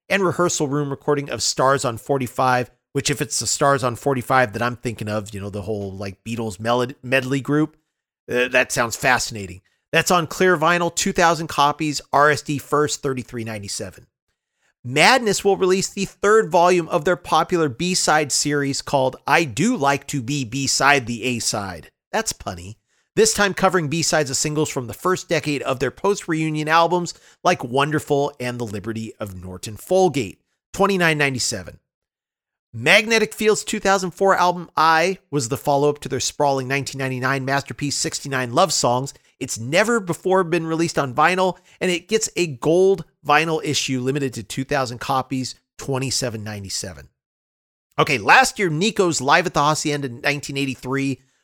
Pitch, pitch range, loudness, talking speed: 140 Hz, 125-165 Hz, -20 LUFS, 150 wpm